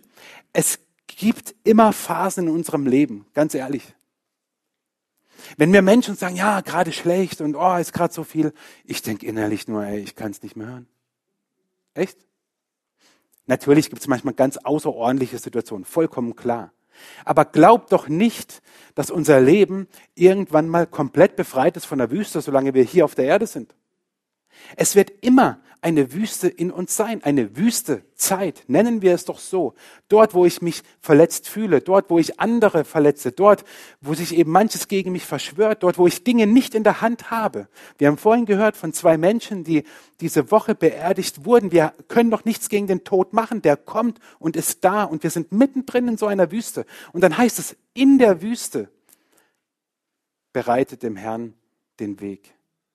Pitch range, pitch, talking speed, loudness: 150-210 Hz, 180 Hz, 175 wpm, -19 LUFS